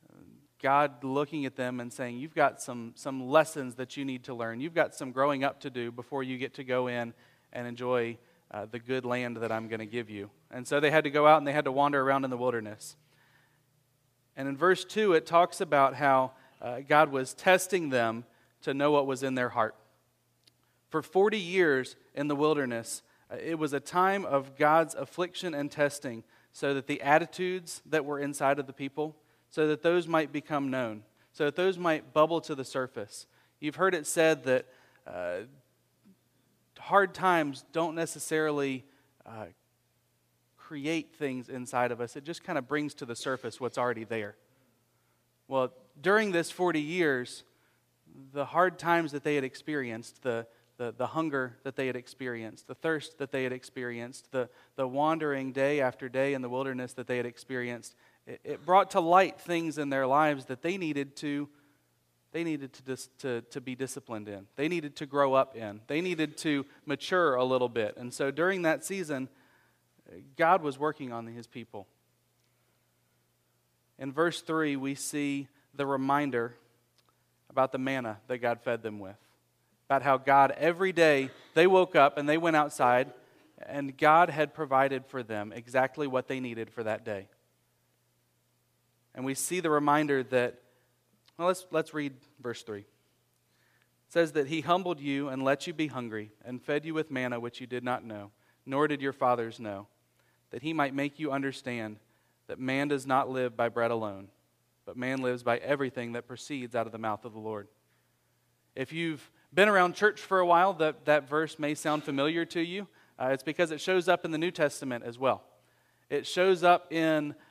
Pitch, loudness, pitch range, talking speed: 135 Hz, -30 LUFS, 120-155 Hz, 185 wpm